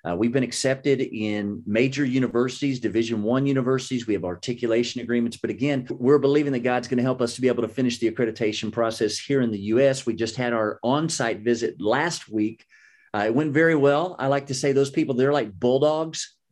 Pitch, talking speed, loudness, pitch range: 125 Hz, 210 wpm, -23 LUFS, 115-140 Hz